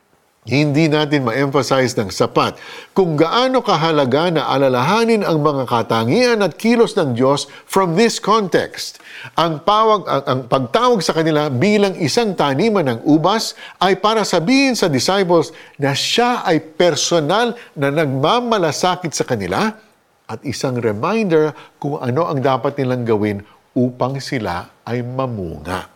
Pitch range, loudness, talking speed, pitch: 130-195 Hz, -16 LUFS, 135 wpm, 155 Hz